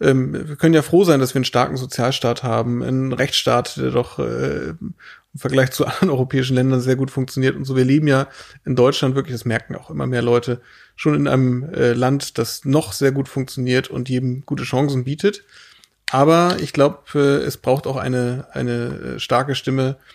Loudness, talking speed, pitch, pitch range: -19 LUFS, 185 wpm, 130 Hz, 125-140 Hz